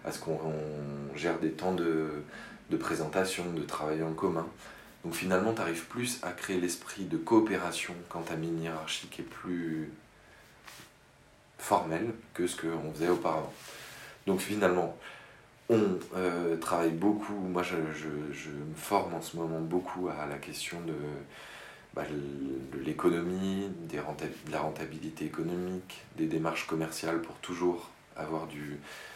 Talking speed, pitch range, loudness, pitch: 145 wpm, 80-90 Hz, -34 LUFS, 80 Hz